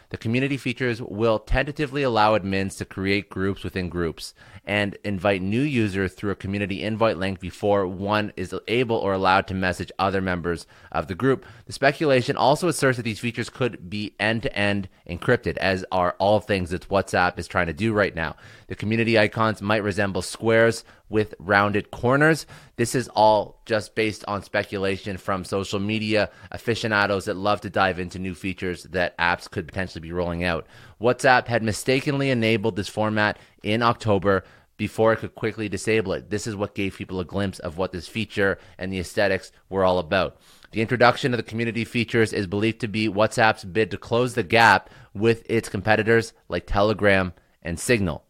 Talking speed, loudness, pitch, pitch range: 185 wpm, -23 LUFS, 105 Hz, 95-115 Hz